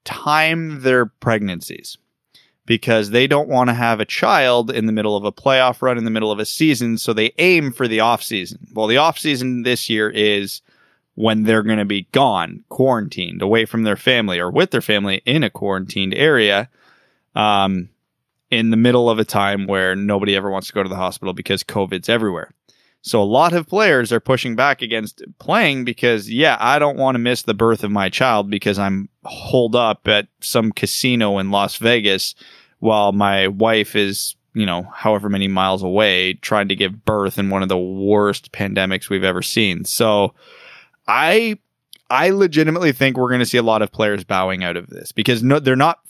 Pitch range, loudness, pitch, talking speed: 100-125 Hz, -17 LUFS, 110 Hz, 200 wpm